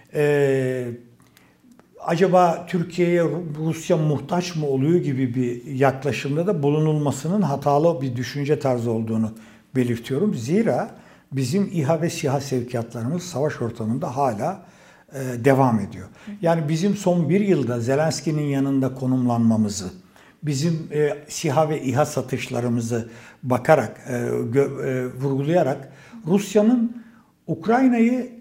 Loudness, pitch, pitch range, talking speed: -22 LUFS, 145 Hz, 125-170 Hz, 95 wpm